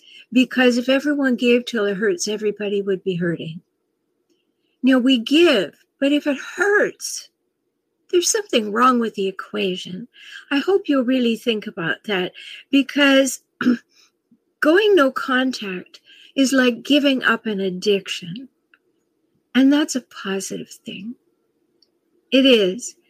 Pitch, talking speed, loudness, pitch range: 265 Hz, 125 wpm, -19 LUFS, 215-345 Hz